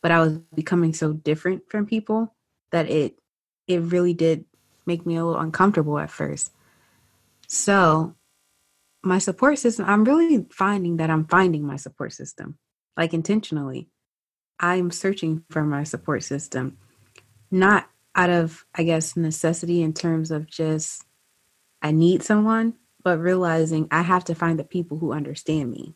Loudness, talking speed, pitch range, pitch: -22 LUFS, 150 wpm, 155-185 Hz, 165 Hz